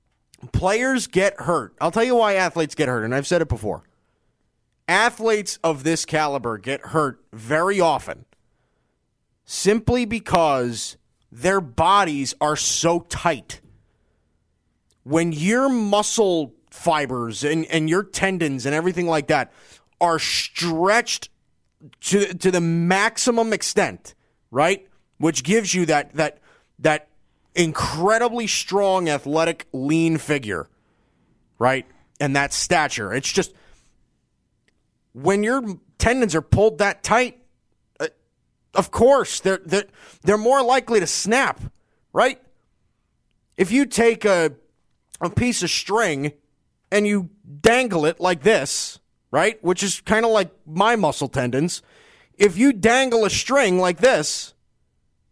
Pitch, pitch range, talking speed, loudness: 180 Hz, 150-215 Hz, 125 wpm, -20 LUFS